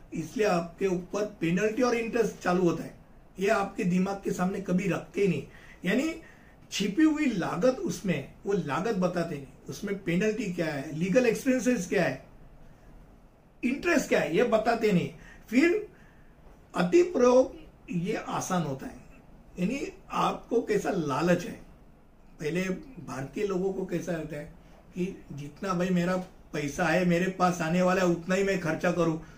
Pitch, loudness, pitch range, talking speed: 185 Hz, -28 LUFS, 170-215 Hz, 155 wpm